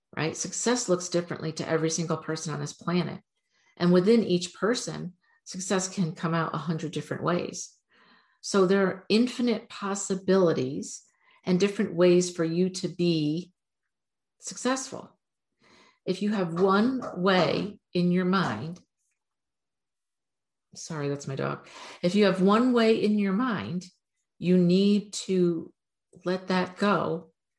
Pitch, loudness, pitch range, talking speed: 185 Hz, -27 LUFS, 170-205 Hz, 135 wpm